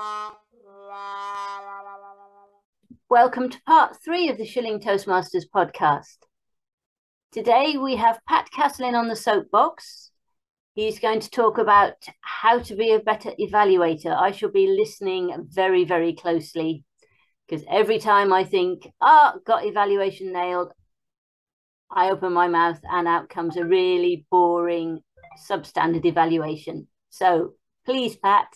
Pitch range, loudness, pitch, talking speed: 180-240 Hz, -21 LUFS, 200 Hz, 125 wpm